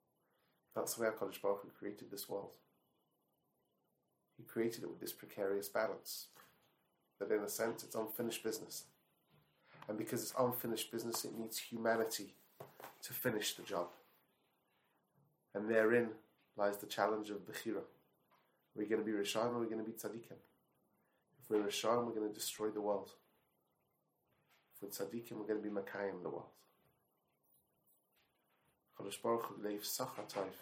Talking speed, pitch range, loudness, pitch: 140 wpm, 105-115 Hz, -41 LUFS, 110 Hz